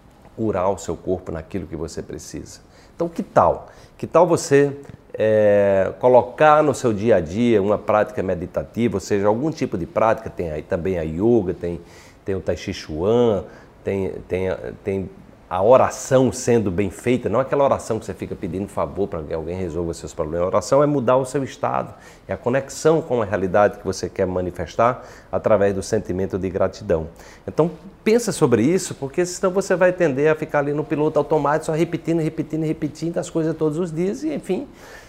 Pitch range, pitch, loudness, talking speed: 95-155 Hz, 120 Hz, -21 LUFS, 190 wpm